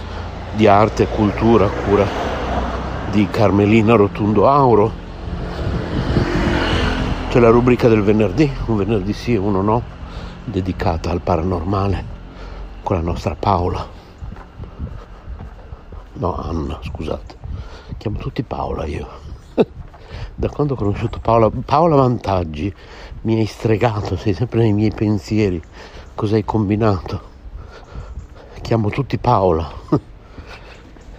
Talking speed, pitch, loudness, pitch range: 105 wpm, 100 Hz, -18 LUFS, 85-110 Hz